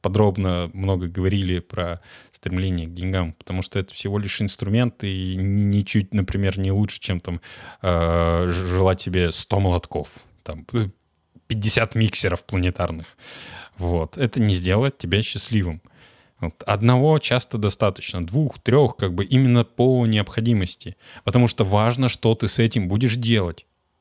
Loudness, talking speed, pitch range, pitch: -21 LUFS, 135 wpm, 90-115 Hz, 100 Hz